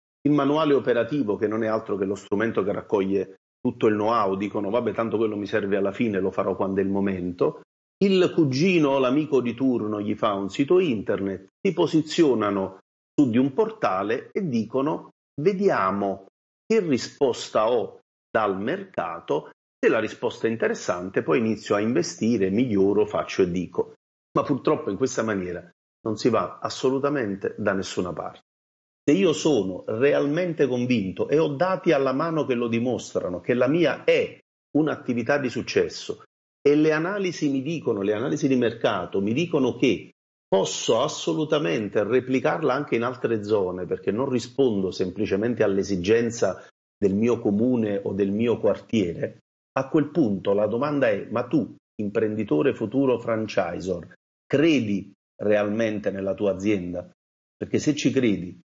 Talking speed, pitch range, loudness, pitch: 155 wpm, 100-150 Hz, -24 LUFS, 115 Hz